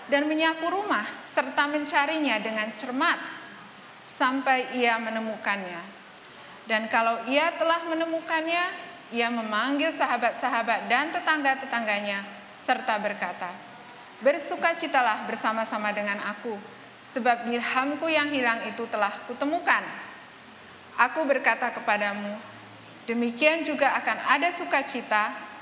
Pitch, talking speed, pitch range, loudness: 245 Hz, 95 wpm, 220-300 Hz, -26 LUFS